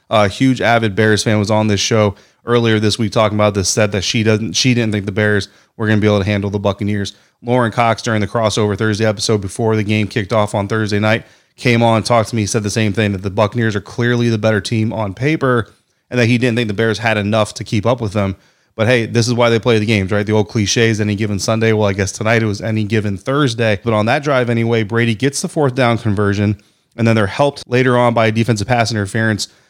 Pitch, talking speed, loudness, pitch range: 110 Hz, 260 wpm, -15 LUFS, 105-115 Hz